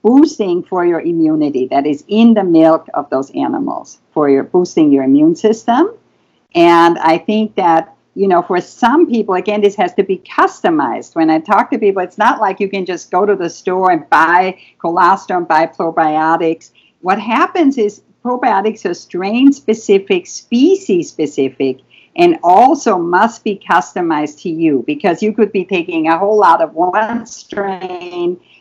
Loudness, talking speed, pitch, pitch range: -13 LUFS, 170 wpm, 185 Hz, 165-220 Hz